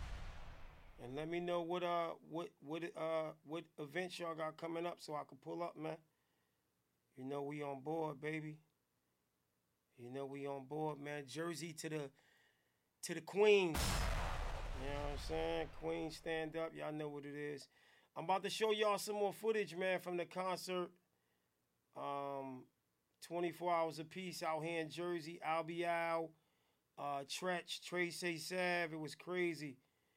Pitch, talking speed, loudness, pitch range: 160 Hz, 165 wpm, -42 LUFS, 140-175 Hz